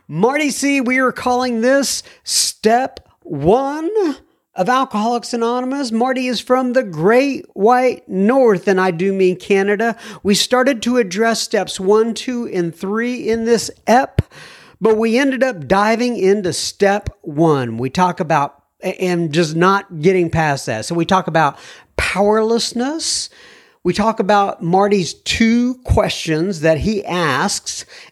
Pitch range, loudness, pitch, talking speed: 185-245 Hz, -16 LUFS, 220 Hz, 140 wpm